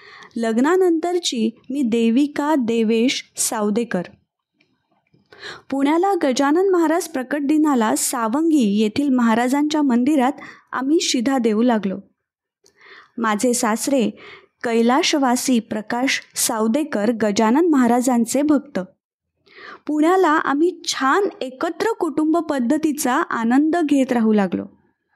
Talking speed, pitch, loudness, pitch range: 85 wpm, 275 Hz, -19 LUFS, 235-315 Hz